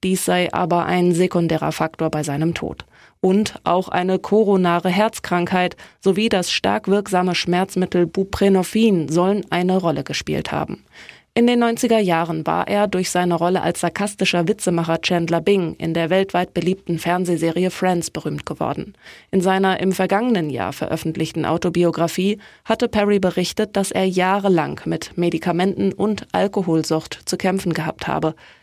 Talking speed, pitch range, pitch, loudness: 145 wpm, 170-195 Hz, 180 Hz, -19 LUFS